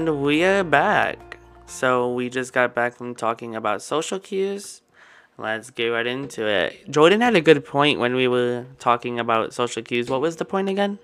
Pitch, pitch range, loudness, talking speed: 125 Hz, 120-160 Hz, -21 LUFS, 195 wpm